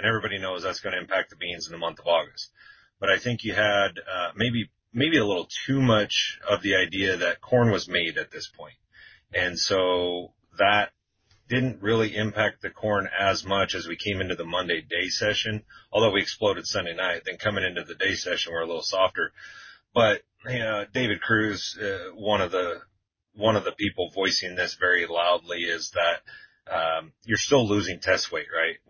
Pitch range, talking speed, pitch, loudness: 95-115 Hz, 195 wpm, 105 Hz, -25 LUFS